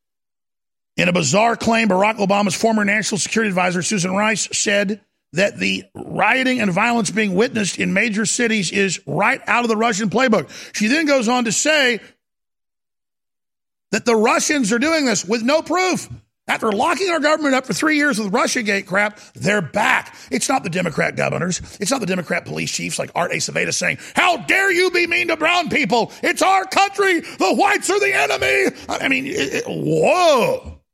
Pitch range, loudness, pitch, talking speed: 200-295 Hz, -18 LUFS, 225 Hz, 185 wpm